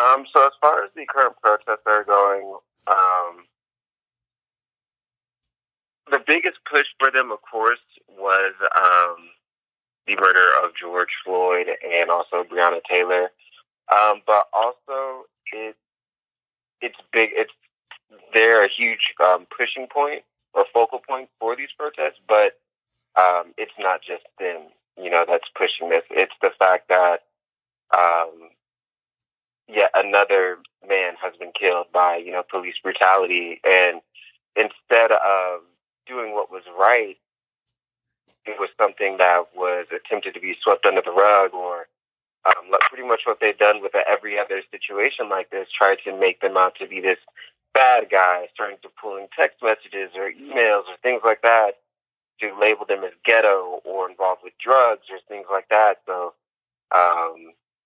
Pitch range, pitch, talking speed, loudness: 90-120 Hz, 100 Hz, 150 wpm, -19 LUFS